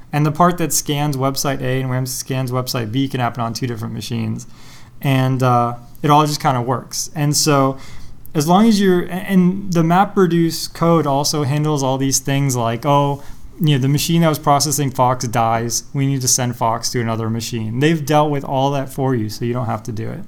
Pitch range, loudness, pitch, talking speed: 125-150 Hz, -17 LUFS, 135 Hz, 215 wpm